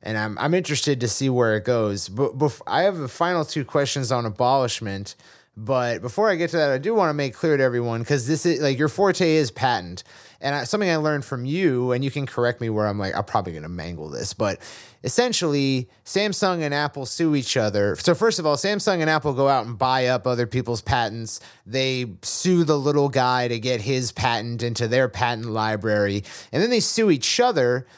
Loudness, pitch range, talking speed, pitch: -22 LUFS, 115-155 Hz, 225 wpm, 130 Hz